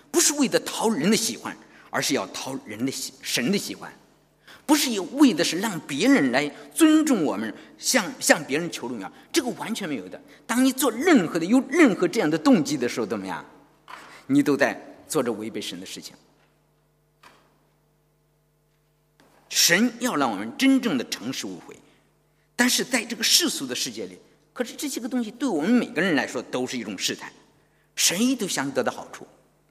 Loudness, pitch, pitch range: -23 LUFS, 250 Hz, 170-270 Hz